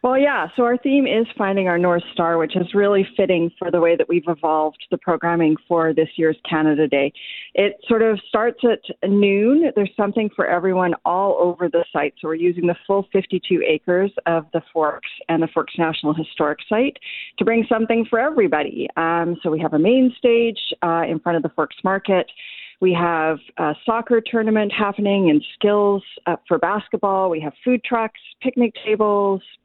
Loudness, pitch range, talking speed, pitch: -19 LUFS, 165-215 Hz, 190 wpm, 185 Hz